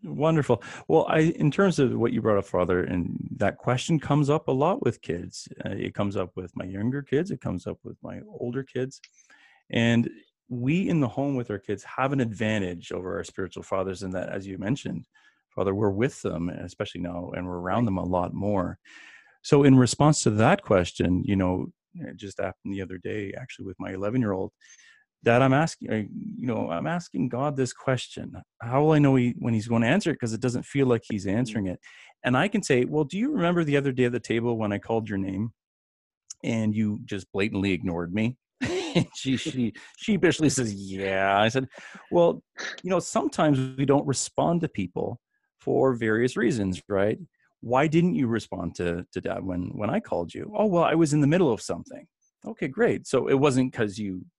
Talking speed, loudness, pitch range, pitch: 210 wpm, -26 LUFS, 95-140 Hz, 115 Hz